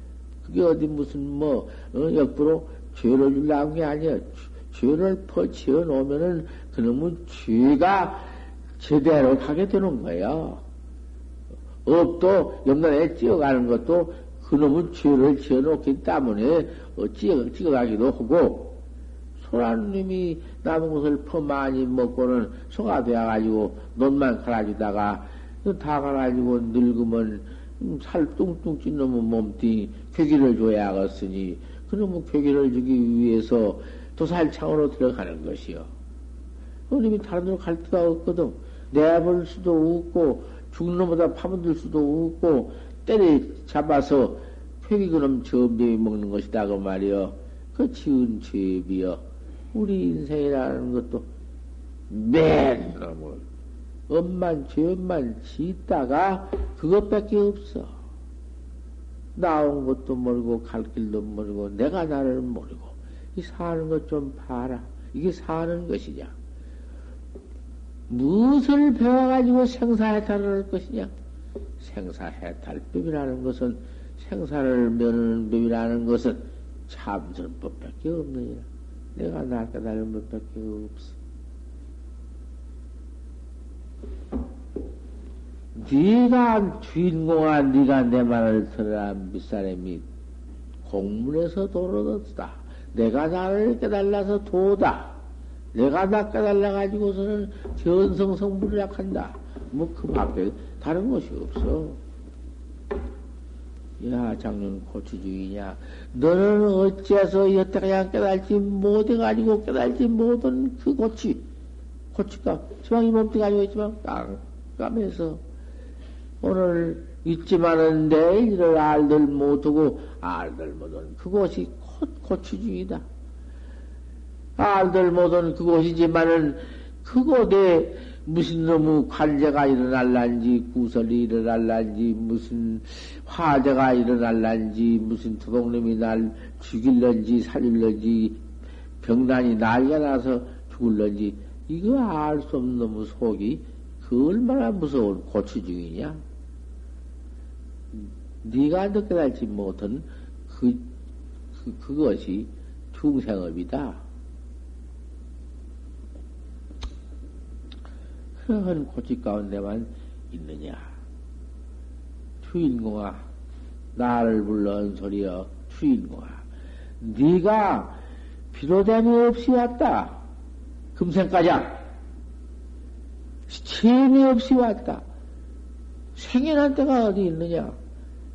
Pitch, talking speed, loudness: 115 Hz, 215 characters per minute, -23 LUFS